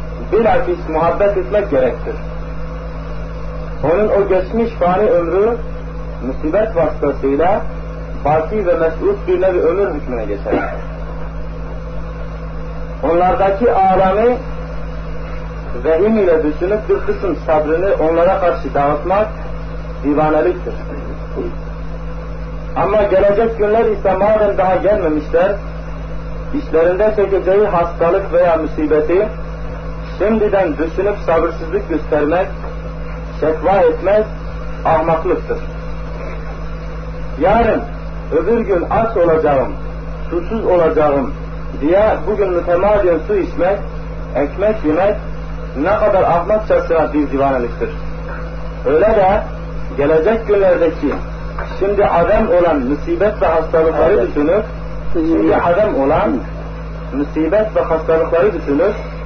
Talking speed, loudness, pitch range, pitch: 90 wpm, -15 LUFS, 160-195 Hz, 165 Hz